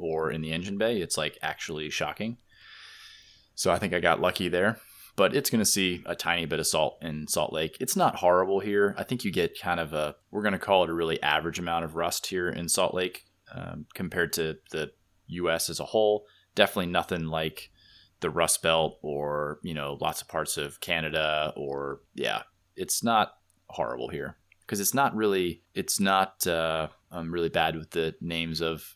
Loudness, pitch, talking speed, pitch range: -28 LUFS, 85 Hz, 195 wpm, 80-100 Hz